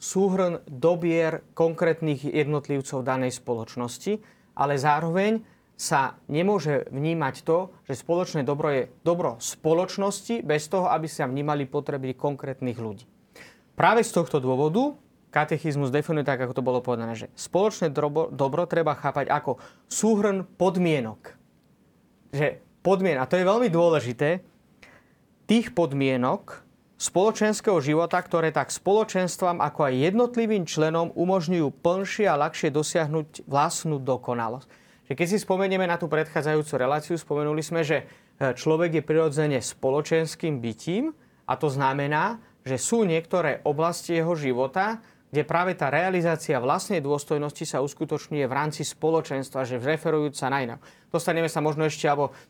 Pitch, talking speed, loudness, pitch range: 155 Hz, 130 wpm, -25 LUFS, 140-175 Hz